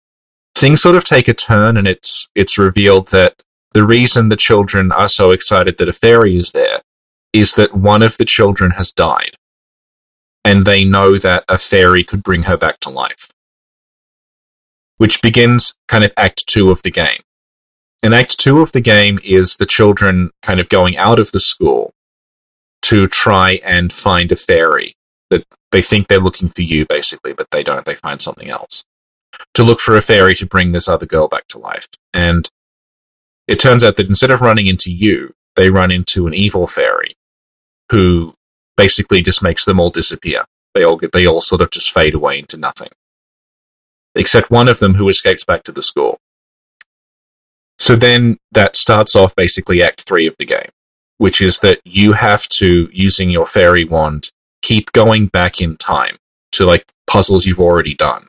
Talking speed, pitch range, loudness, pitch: 185 wpm, 90-110 Hz, -11 LUFS, 95 Hz